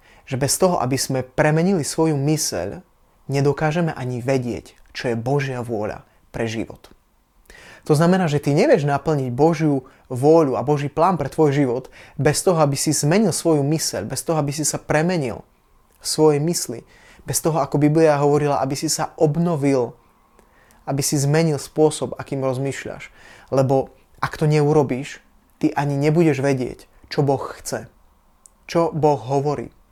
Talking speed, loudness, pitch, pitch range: 150 wpm, -20 LUFS, 145 Hz, 135-155 Hz